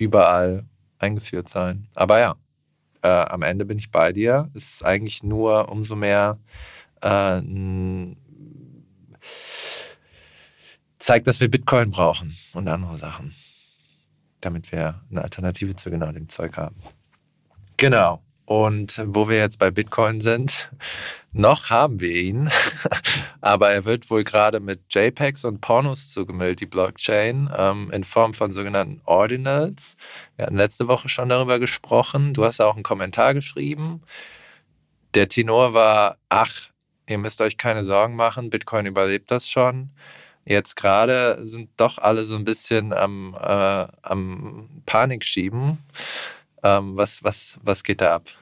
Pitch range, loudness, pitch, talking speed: 95-125 Hz, -21 LUFS, 105 Hz, 140 wpm